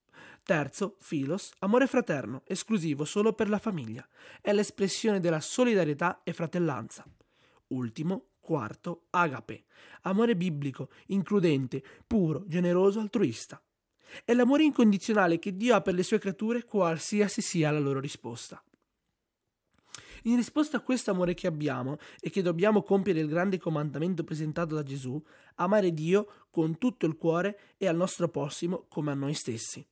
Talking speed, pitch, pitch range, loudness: 140 wpm, 180 Hz, 155-210 Hz, -29 LUFS